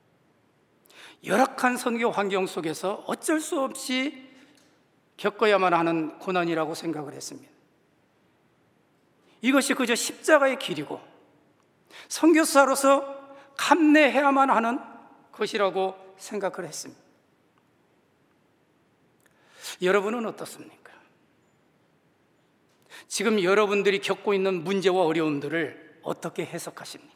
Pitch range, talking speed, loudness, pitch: 185-270 Hz, 230 characters per minute, -24 LUFS, 215 Hz